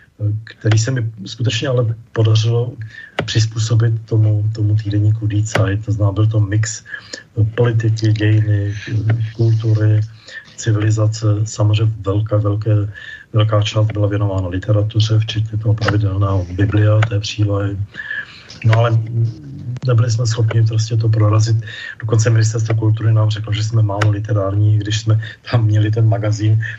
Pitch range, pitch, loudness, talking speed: 105-115 Hz, 110 Hz, -17 LUFS, 130 wpm